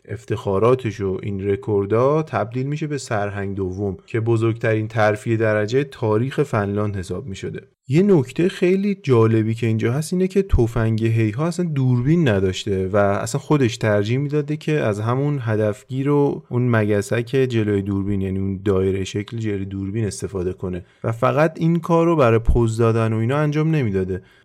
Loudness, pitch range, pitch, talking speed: -20 LUFS, 100-140 Hz, 115 Hz, 160 wpm